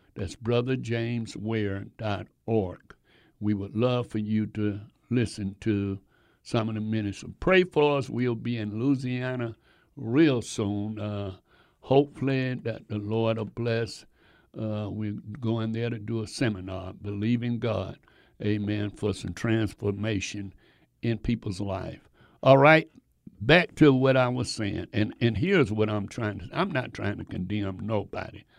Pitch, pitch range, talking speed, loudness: 110 Hz, 105-120 Hz, 145 wpm, -27 LUFS